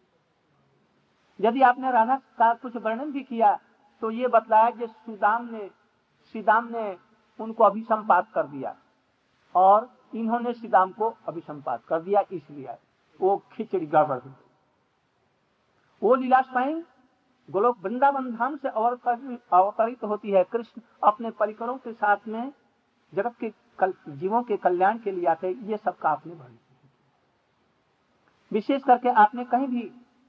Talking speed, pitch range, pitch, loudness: 135 wpm, 195-245 Hz, 220 Hz, -25 LUFS